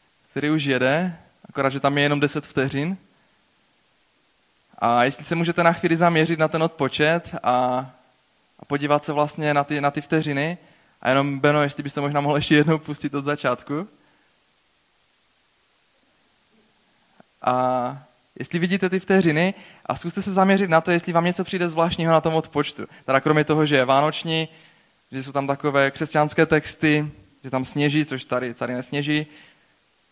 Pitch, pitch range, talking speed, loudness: 150 Hz, 140-165 Hz, 160 wpm, -22 LUFS